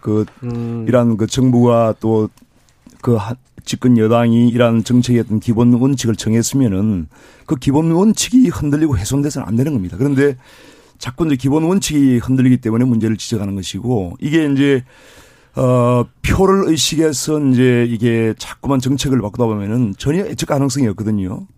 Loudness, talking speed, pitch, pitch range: -15 LUFS, 335 characters per minute, 125 Hz, 115-140 Hz